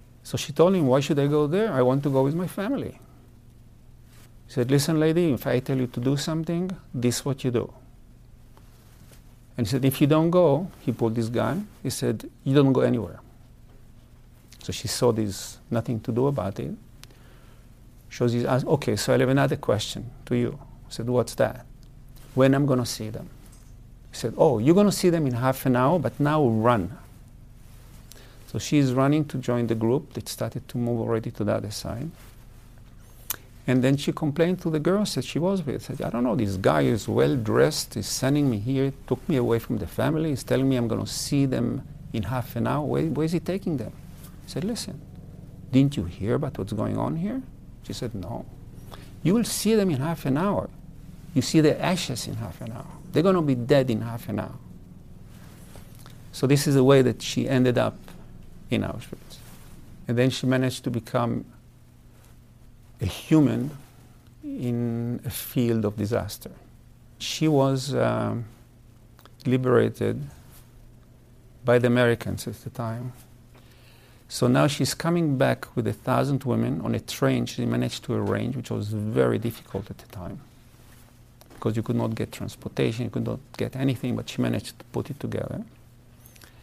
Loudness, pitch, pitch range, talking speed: -25 LUFS, 125 Hz, 115-140 Hz, 190 wpm